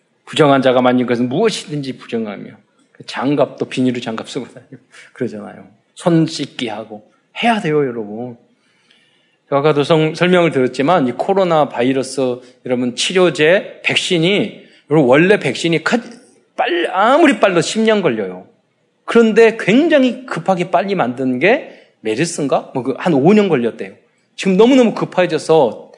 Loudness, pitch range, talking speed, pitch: -15 LUFS, 130-205 Hz, 305 characters per minute, 160 Hz